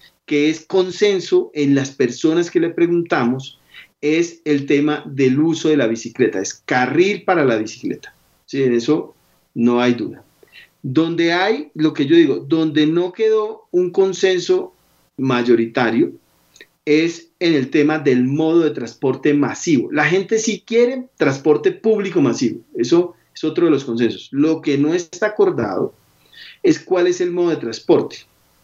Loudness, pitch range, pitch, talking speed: -17 LUFS, 135-220 Hz, 160 Hz, 155 wpm